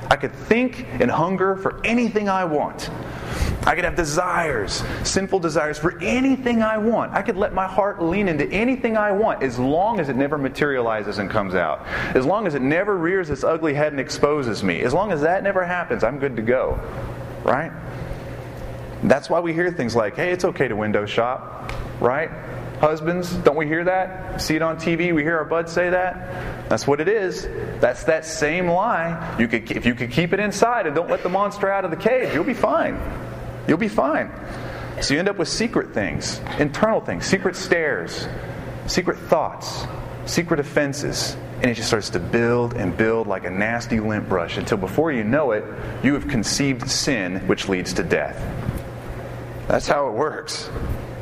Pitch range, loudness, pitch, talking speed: 130-190 Hz, -22 LUFS, 165 Hz, 195 wpm